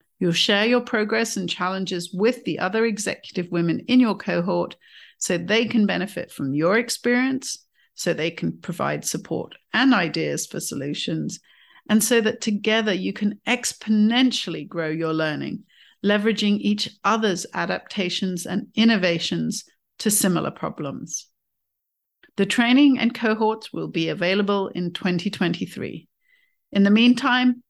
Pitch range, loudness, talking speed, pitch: 180-235 Hz, -22 LUFS, 130 wpm, 210 Hz